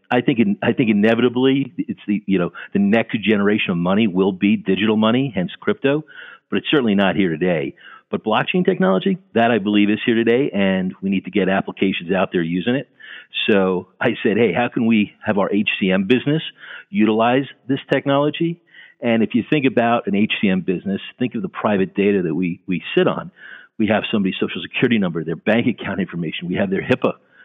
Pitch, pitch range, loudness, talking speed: 110 Hz, 100-135 Hz, -19 LUFS, 200 wpm